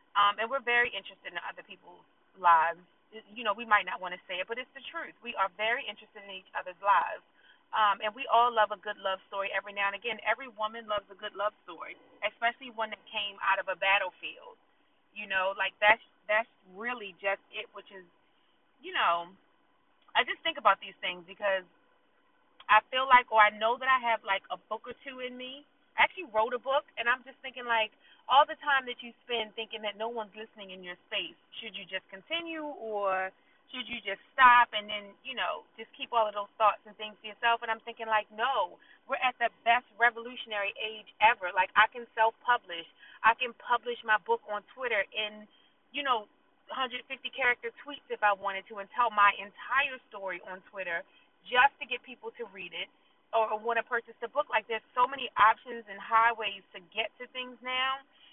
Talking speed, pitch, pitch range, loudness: 210 wpm, 220 Hz, 200-245 Hz, -30 LUFS